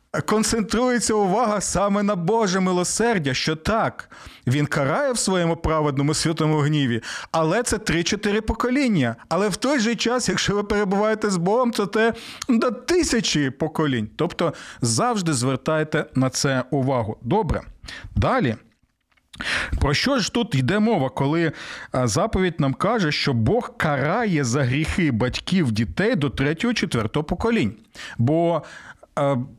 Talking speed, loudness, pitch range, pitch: 130 wpm, -22 LUFS, 140-215 Hz, 170 Hz